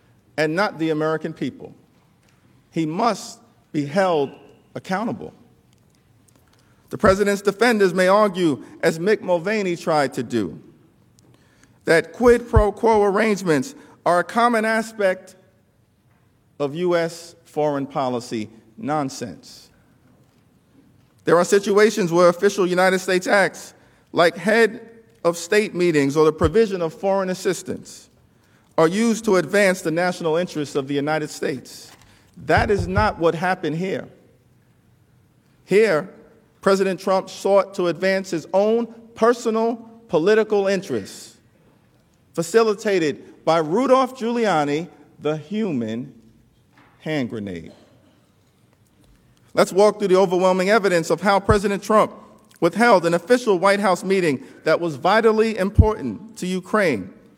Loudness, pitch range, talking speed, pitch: -20 LUFS, 160-210 Hz, 115 wpm, 185 Hz